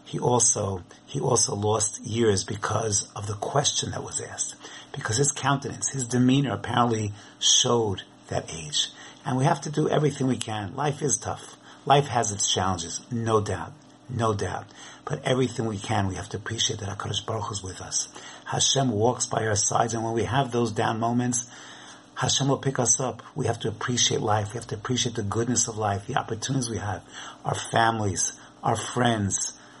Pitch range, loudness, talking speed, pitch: 105-125 Hz, -25 LUFS, 185 wpm, 115 Hz